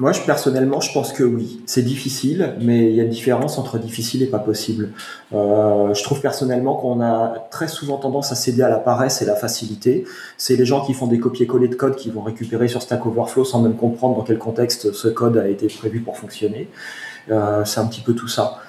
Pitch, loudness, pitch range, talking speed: 120 Hz, -19 LUFS, 115-130 Hz, 230 wpm